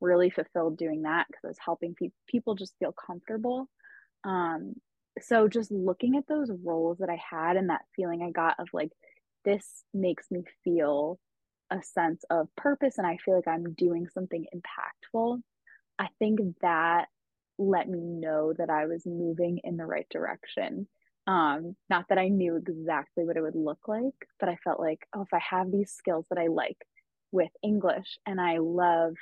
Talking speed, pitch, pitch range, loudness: 185 wpm, 180 Hz, 170-200 Hz, -30 LUFS